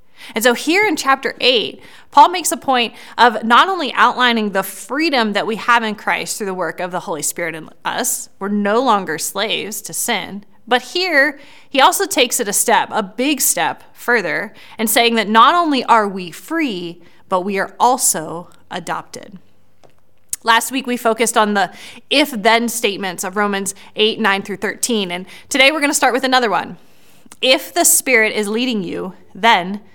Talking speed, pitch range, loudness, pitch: 185 wpm, 195-260 Hz, -16 LUFS, 230 Hz